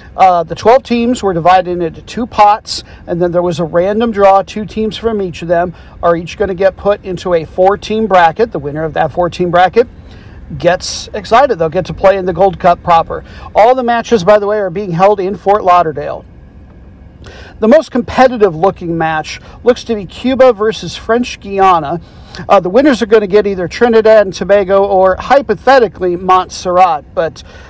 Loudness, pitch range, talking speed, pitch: -11 LUFS, 175-220 Hz, 195 wpm, 195 Hz